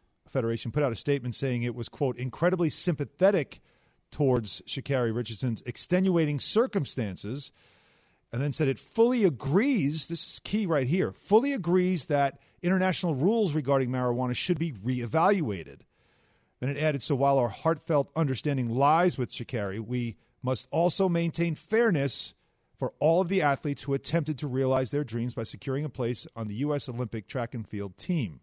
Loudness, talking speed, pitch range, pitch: -28 LUFS, 160 wpm, 120-170 Hz, 140 Hz